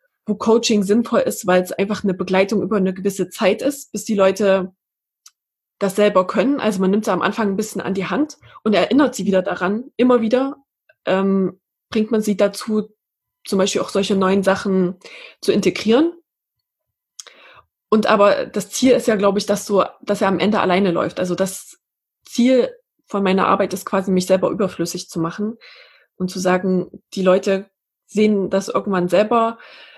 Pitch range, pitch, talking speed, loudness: 190-225 Hz, 200 Hz, 180 wpm, -18 LUFS